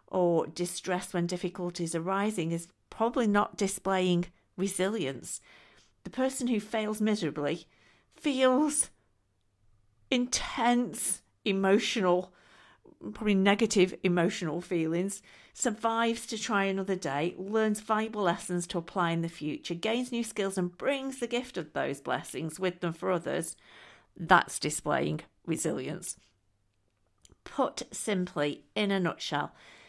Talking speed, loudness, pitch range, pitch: 115 wpm, -30 LUFS, 170-220 Hz, 185 Hz